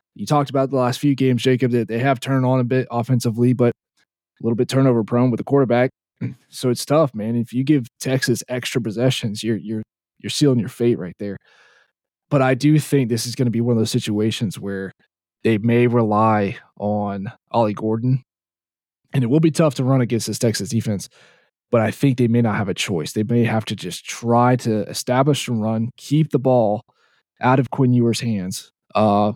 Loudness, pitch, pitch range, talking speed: -20 LUFS, 120 Hz, 110-130 Hz, 210 wpm